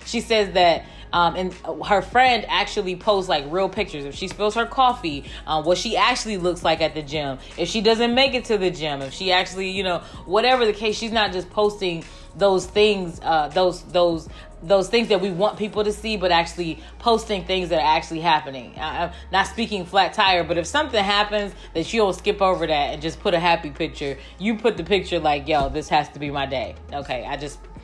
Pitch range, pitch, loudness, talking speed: 165-210 Hz, 185 Hz, -21 LUFS, 220 wpm